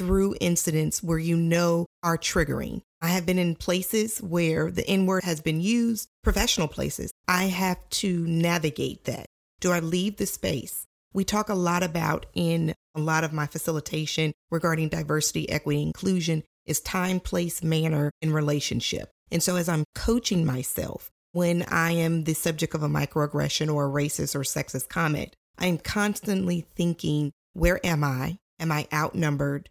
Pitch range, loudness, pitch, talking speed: 155-180 Hz, -26 LUFS, 165 Hz, 165 wpm